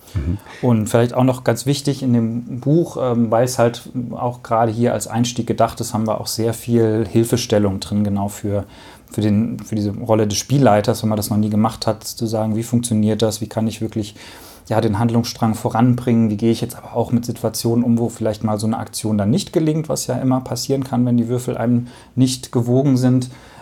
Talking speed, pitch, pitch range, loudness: 215 wpm, 115 Hz, 110-125 Hz, -19 LUFS